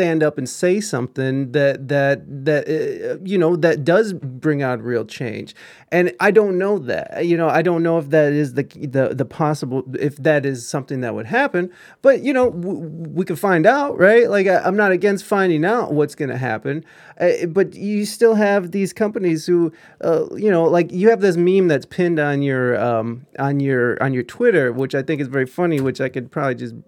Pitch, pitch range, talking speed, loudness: 160 Hz, 140-190 Hz, 220 wpm, -18 LUFS